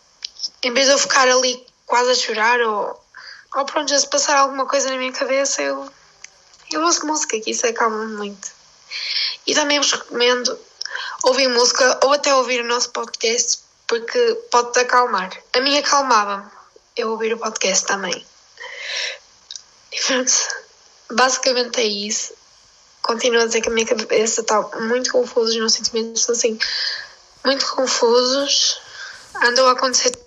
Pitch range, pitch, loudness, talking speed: 240-315 Hz, 260 Hz, -18 LUFS, 150 wpm